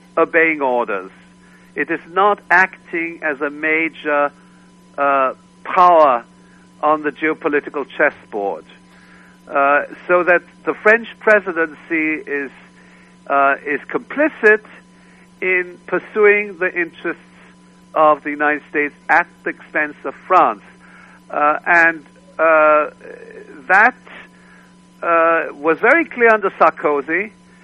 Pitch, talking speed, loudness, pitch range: 165 Hz, 105 wpm, -16 LUFS, 145-185 Hz